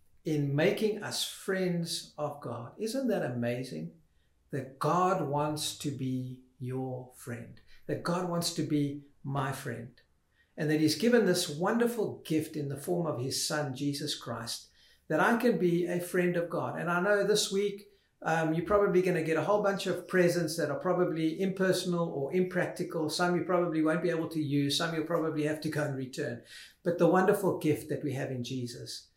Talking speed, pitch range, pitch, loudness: 190 wpm, 140-180 Hz, 160 Hz, -31 LUFS